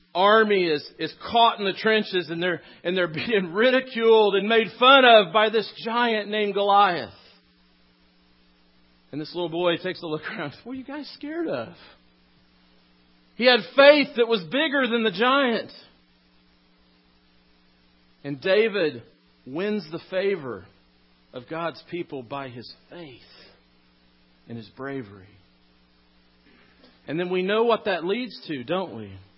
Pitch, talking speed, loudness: 165 Hz, 140 wpm, -22 LUFS